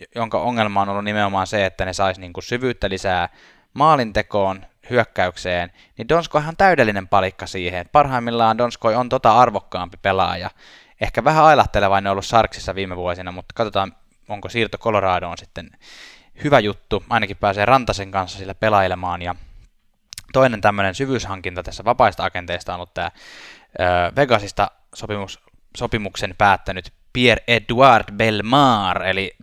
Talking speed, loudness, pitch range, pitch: 135 wpm, -19 LUFS, 95-120 Hz, 105 Hz